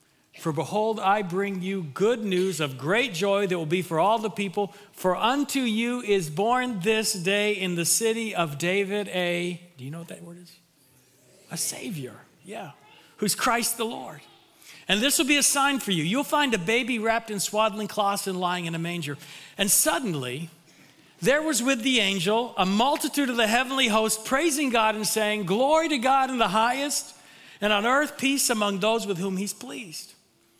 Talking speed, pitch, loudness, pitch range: 190 wpm, 205 Hz, -24 LUFS, 180-240 Hz